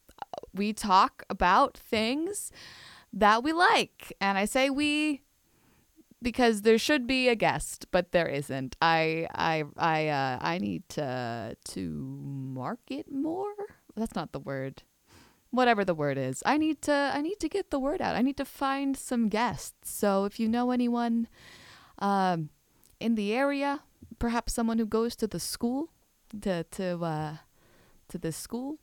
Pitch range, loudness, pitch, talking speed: 160-265 Hz, -29 LUFS, 225 Hz, 160 wpm